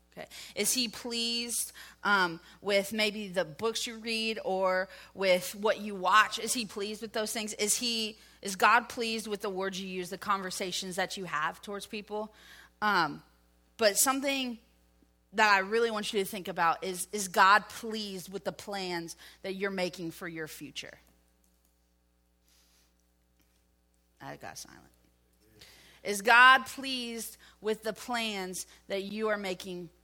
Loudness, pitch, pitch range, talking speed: -30 LUFS, 195 Hz, 170-220 Hz, 150 wpm